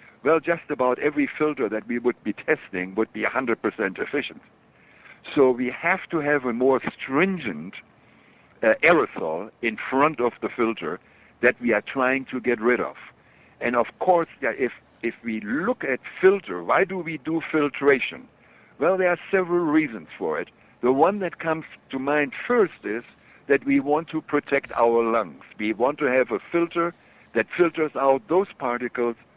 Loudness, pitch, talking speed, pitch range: -24 LUFS, 145 Hz, 170 wpm, 125-170 Hz